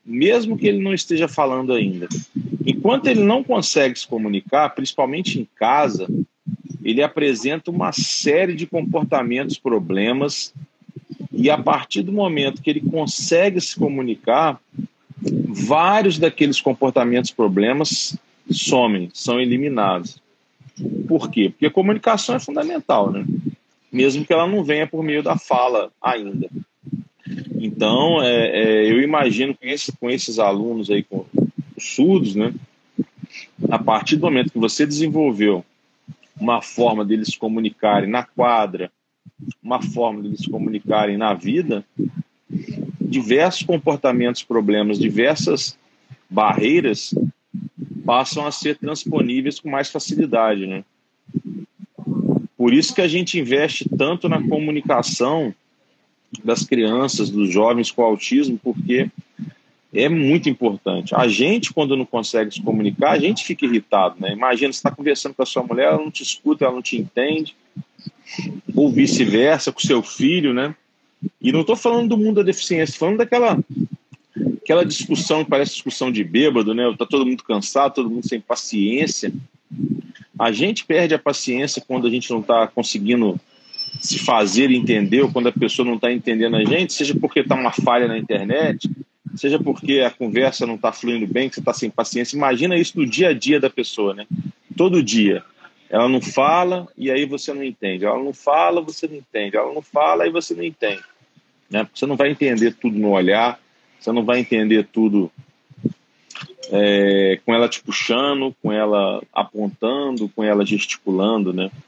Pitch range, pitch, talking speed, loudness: 115-165 Hz, 135 Hz, 155 wpm, -19 LUFS